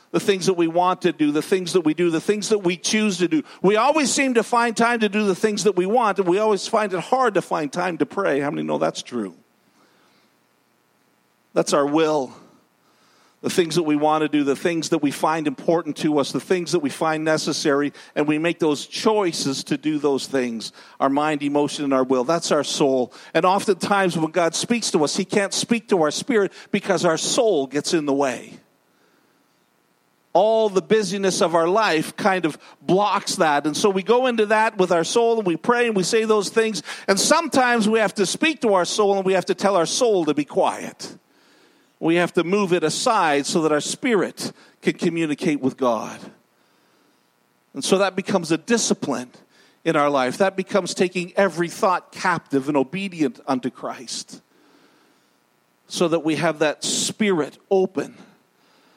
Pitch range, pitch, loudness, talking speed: 150-205 Hz, 175 Hz, -21 LUFS, 200 wpm